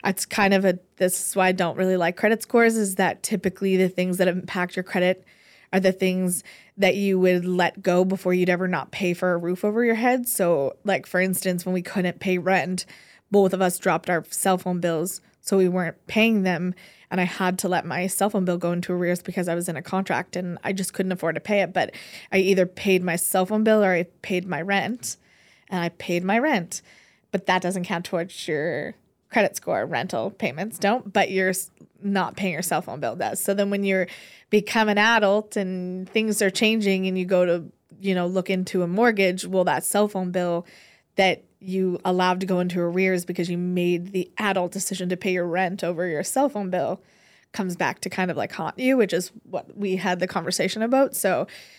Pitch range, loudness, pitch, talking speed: 180-195 Hz, -23 LUFS, 185 Hz, 225 wpm